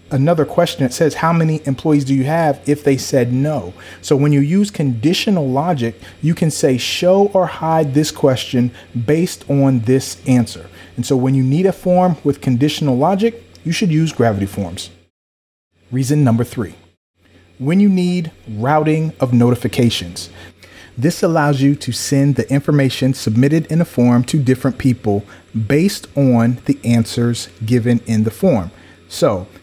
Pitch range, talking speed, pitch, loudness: 115-155 Hz, 160 wpm, 135 Hz, -16 LUFS